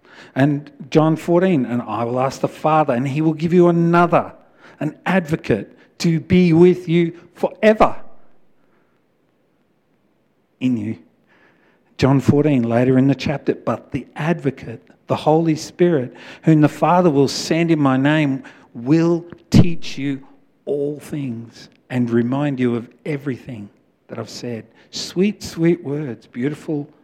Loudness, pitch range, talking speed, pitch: -18 LUFS, 130-170 Hz, 135 wpm, 150 Hz